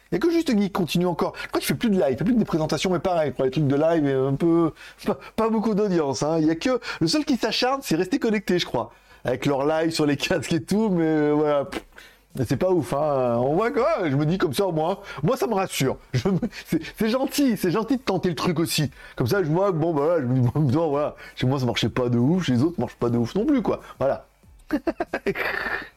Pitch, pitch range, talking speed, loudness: 170 Hz, 145-210 Hz, 275 wpm, -23 LUFS